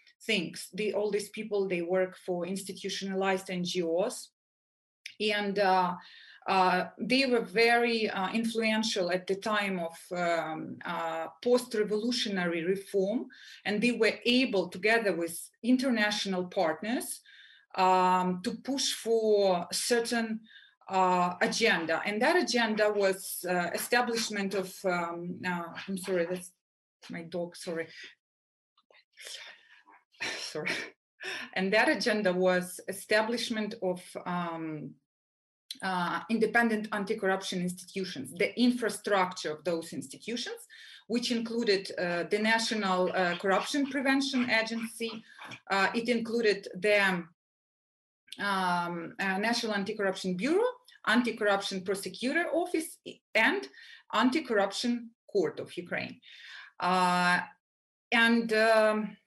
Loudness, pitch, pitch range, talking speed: -30 LUFS, 200 Hz, 180-230 Hz, 110 wpm